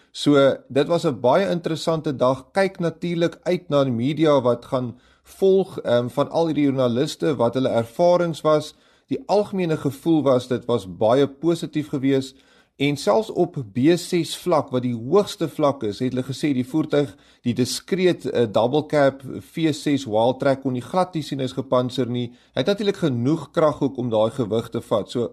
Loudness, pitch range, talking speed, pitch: -22 LUFS, 125-165 Hz, 170 wpm, 145 Hz